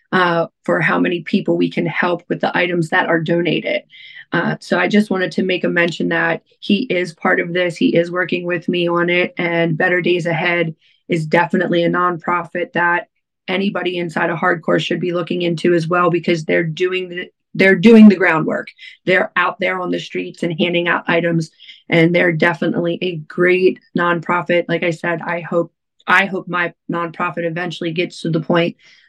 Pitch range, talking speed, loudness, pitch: 170-180 Hz, 190 wpm, -17 LUFS, 175 Hz